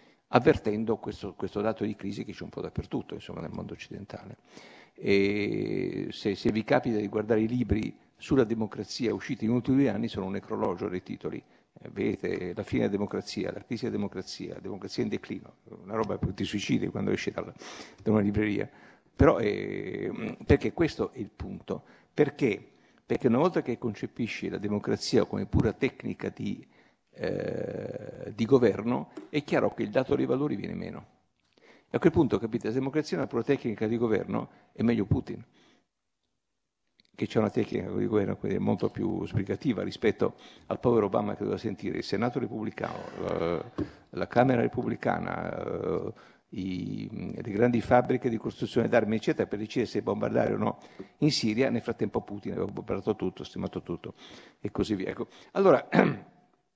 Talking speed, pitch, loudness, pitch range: 170 wpm, 110 Hz, -30 LUFS, 105-120 Hz